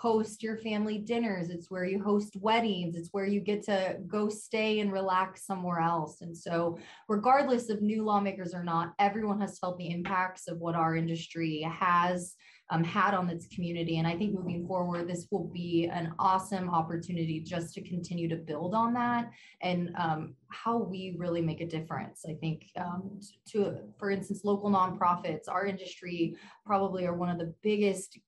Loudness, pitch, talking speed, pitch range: -32 LUFS, 185 Hz, 180 wpm, 170-205 Hz